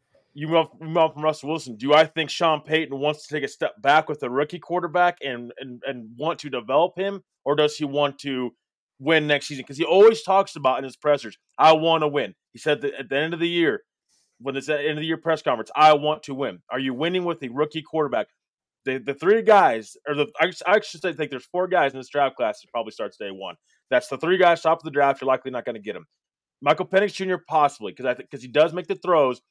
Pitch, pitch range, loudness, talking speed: 155 Hz, 140-170 Hz, -22 LUFS, 260 wpm